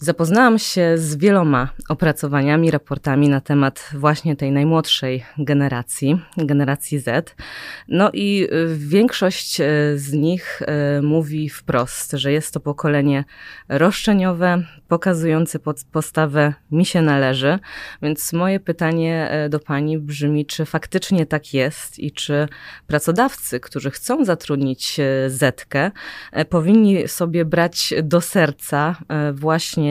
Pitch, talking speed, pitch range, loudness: 155 Hz, 110 wpm, 145-170 Hz, -19 LUFS